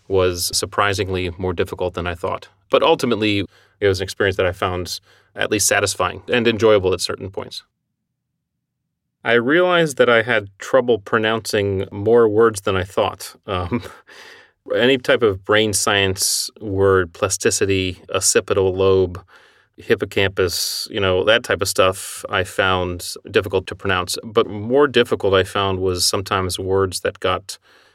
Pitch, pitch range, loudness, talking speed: 100 Hz, 95-115 Hz, -18 LUFS, 145 wpm